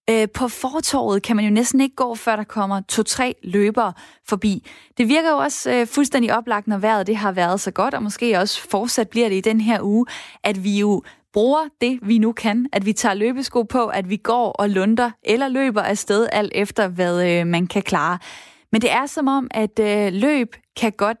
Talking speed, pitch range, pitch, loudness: 205 wpm, 205-245 Hz, 220 Hz, -20 LUFS